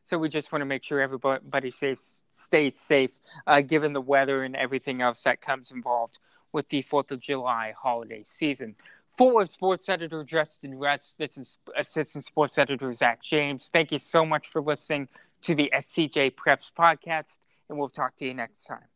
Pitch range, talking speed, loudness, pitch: 130-155 Hz, 185 wpm, -26 LUFS, 145 Hz